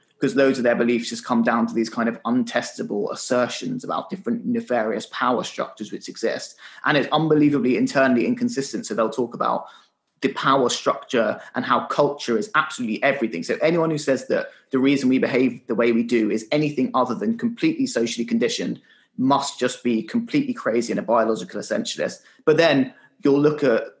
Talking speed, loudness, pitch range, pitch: 185 wpm, -22 LUFS, 120-155 Hz, 135 Hz